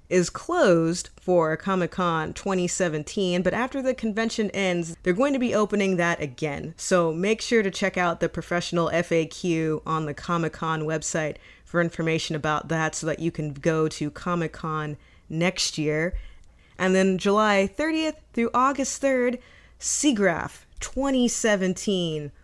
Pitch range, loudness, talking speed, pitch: 160-205 Hz, -25 LUFS, 145 wpm, 175 Hz